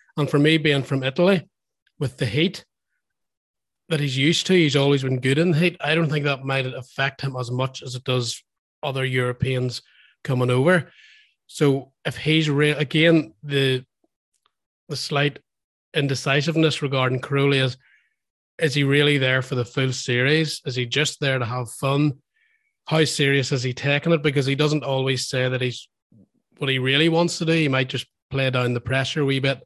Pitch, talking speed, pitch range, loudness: 140 Hz, 185 wpm, 130-155 Hz, -21 LUFS